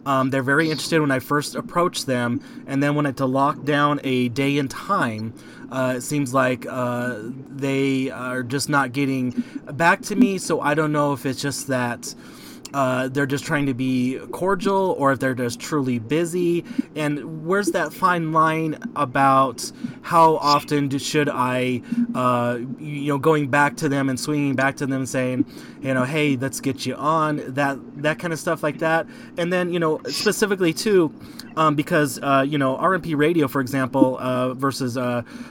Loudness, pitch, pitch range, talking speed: -22 LUFS, 140 Hz, 130-160 Hz, 190 wpm